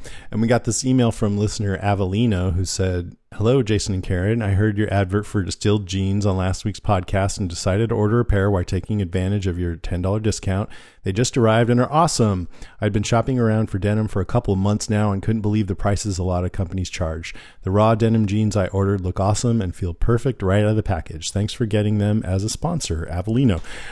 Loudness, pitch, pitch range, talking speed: -21 LUFS, 105 Hz, 95-110 Hz, 225 wpm